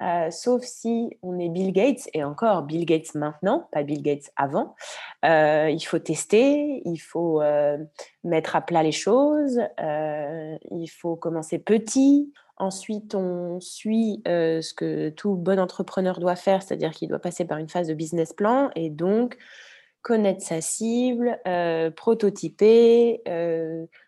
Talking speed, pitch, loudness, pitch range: 155 wpm, 175 Hz, -24 LUFS, 160-220 Hz